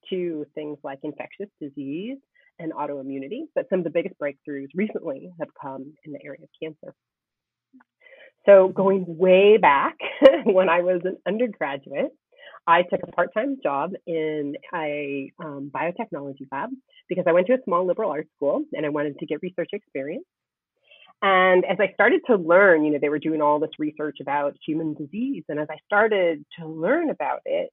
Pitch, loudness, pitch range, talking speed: 170 Hz, -22 LUFS, 150-200 Hz, 175 wpm